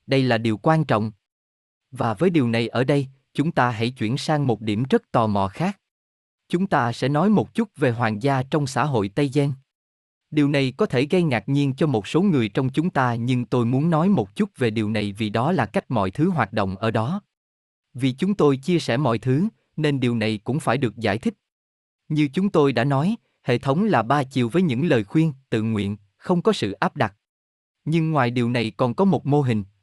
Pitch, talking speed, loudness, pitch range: 135 Hz, 230 wpm, -22 LUFS, 115-160 Hz